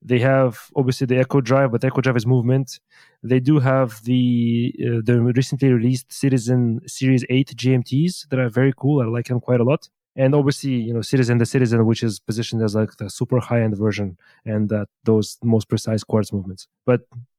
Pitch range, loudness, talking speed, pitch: 115-130 Hz, -20 LUFS, 200 wpm, 125 Hz